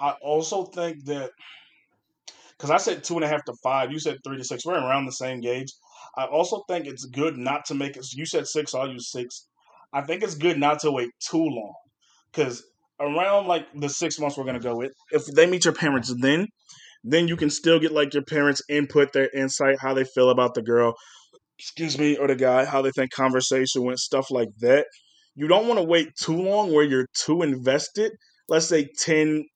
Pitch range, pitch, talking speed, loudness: 130-160 Hz, 145 Hz, 220 wpm, -24 LUFS